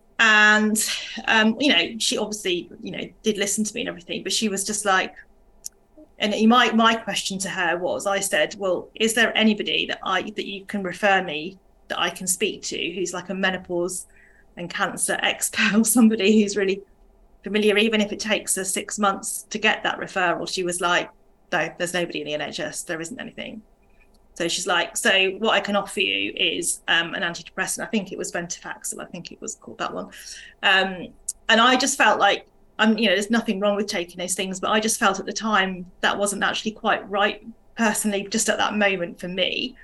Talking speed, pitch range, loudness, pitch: 210 wpm, 190-220 Hz, -22 LUFS, 200 Hz